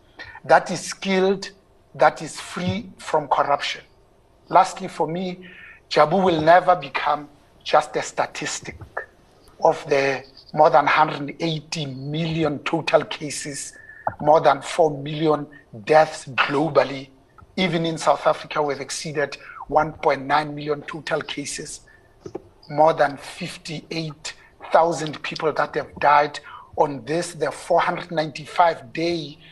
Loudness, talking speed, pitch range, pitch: -22 LUFS, 110 wpm, 145-170 Hz, 155 Hz